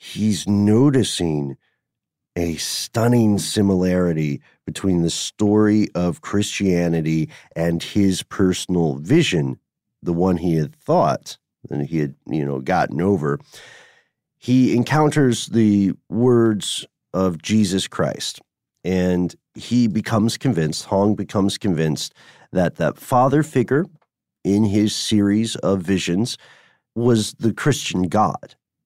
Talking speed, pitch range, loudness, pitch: 110 wpm, 85-110 Hz, -20 LUFS, 100 Hz